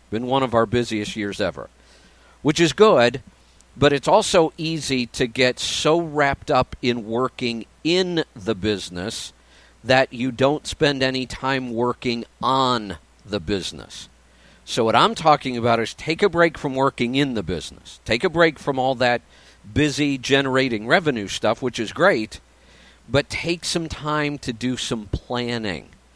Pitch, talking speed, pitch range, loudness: 125 Hz, 160 wpm, 105-145 Hz, -21 LUFS